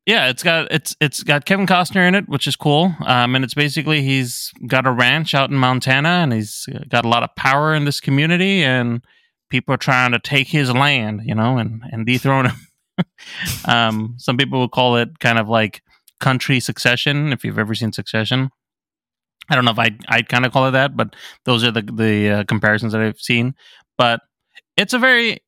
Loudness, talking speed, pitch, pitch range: -17 LUFS, 210 wpm, 130 Hz, 115-145 Hz